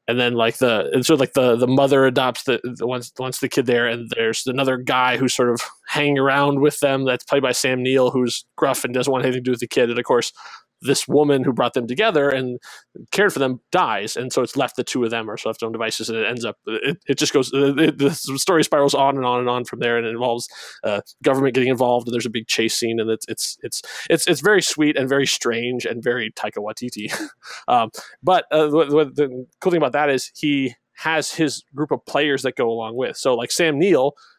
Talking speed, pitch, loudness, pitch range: 250 wpm, 130 Hz, -20 LUFS, 120-140 Hz